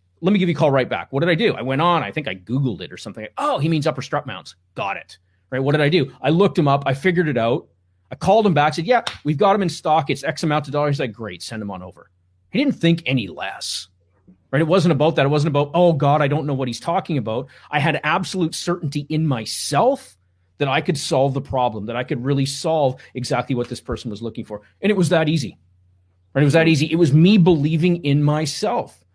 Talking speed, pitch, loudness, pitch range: 265 wpm, 145 Hz, -19 LUFS, 115-165 Hz